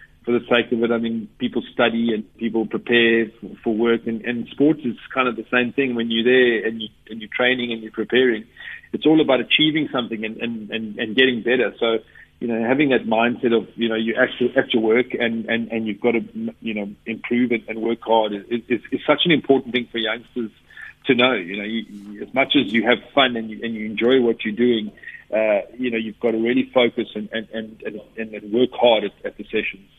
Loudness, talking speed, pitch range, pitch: -20 LUFS, 240 wpm, 110-125 Hz, 115 Hz